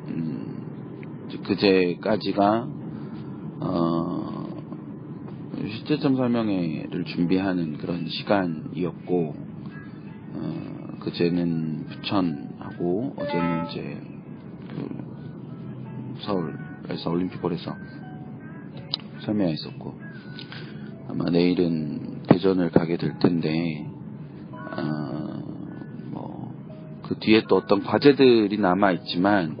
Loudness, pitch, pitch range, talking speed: -25 LUFS, 90 Hz, 85-100 Hz, 170 characters per minute